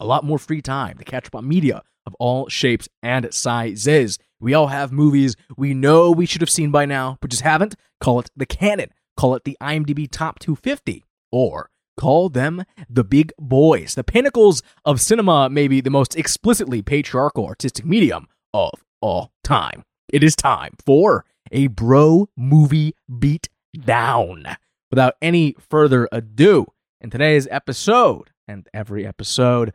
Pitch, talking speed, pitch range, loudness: 140 Hz, 160 wpm, 125-155 Hz, -18 LUFS